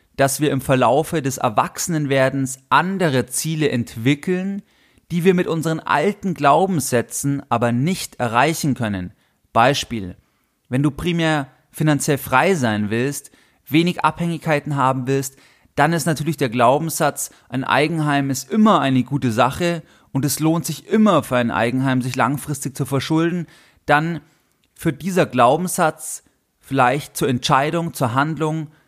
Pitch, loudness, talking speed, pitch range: 145 Hz, -19 LUFS, 135 wpm, 130-160 Hz